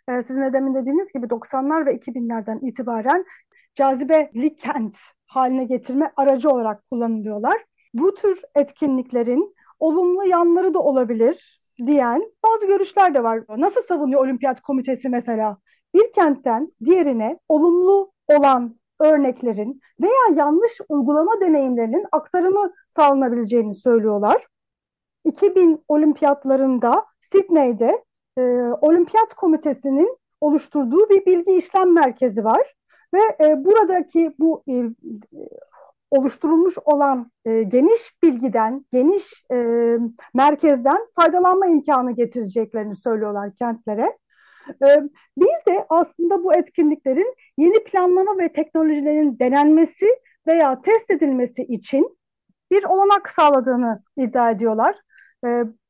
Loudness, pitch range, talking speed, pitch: -18 LUFS, 250-360 Hz, 105 wpm, 295 Hz